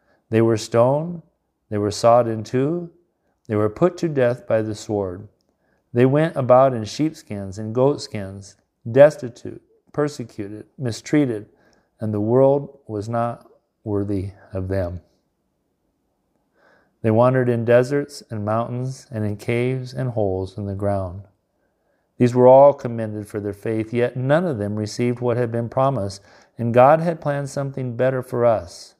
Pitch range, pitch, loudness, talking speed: 105-130 Hz, 120 Hz, -20 LUFS, 150 wpm